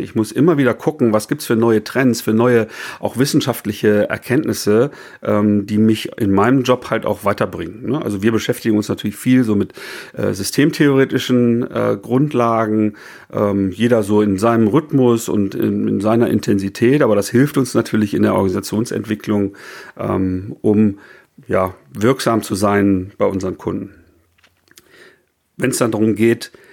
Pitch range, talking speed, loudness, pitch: 100-120 Hz, 160 wpm, -17 LUFS, 110 Hz